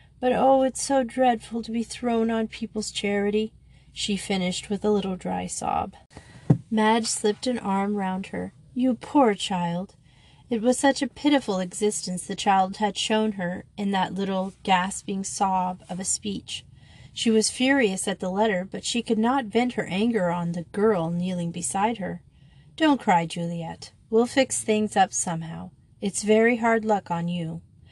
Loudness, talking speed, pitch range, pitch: -25 LUFS, 170 wpm, 180-230 Hz, 205 Hz